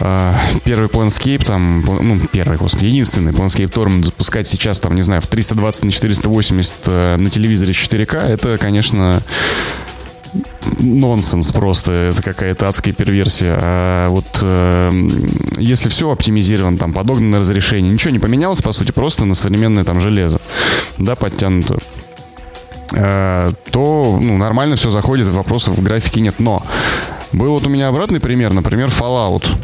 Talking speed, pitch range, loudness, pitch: 135 wpm, 95-115 Hz, -14 LUFS, 105 Hz